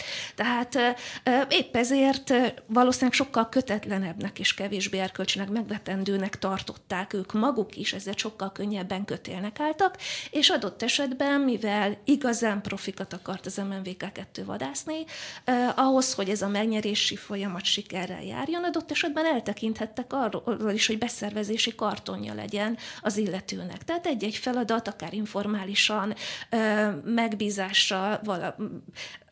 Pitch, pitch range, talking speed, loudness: 215 Hz, 195-250 Hz, 115 wpm, -27 LUFS